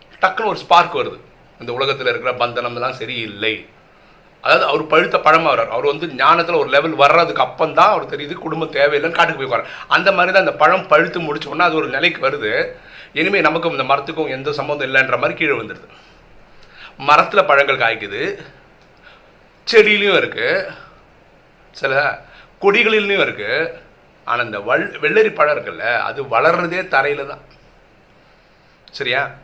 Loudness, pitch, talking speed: -16 LUFS, 170 Hz, 140 wpm